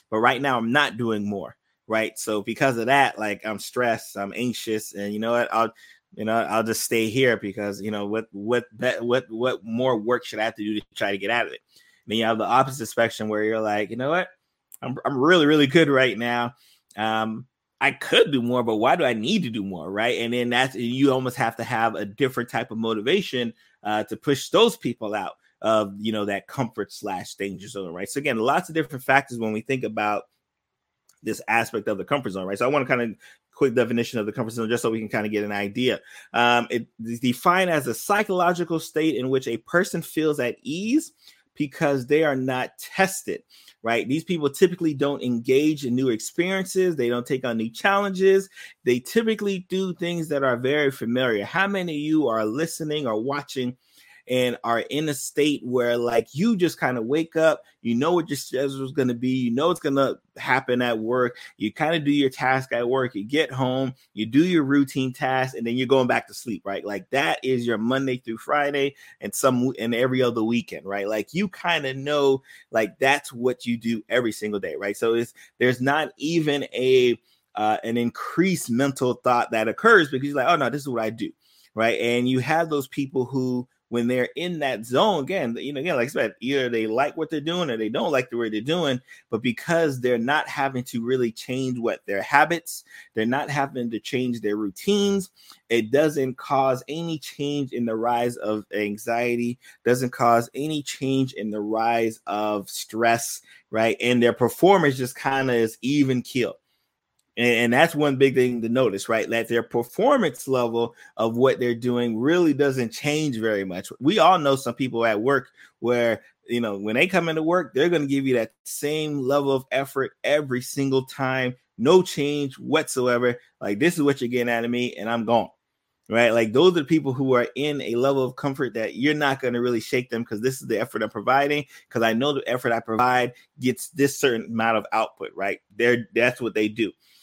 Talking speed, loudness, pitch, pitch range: 215 wpm, -23 LUFS, 125 Hz, 115-145 Hz